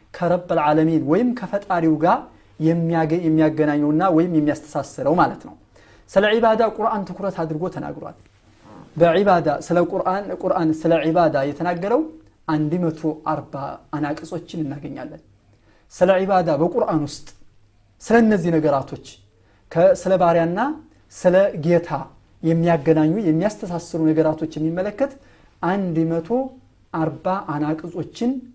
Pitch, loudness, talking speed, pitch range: 165 Hz, -20 LUFS, 90 wpm, 150-185 Hz